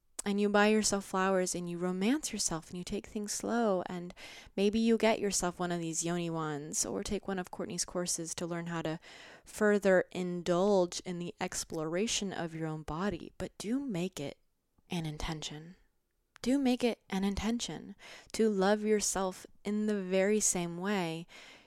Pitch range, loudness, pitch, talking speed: 175-210 Hz, -33 LUFS, 190 Hz, 170 wpm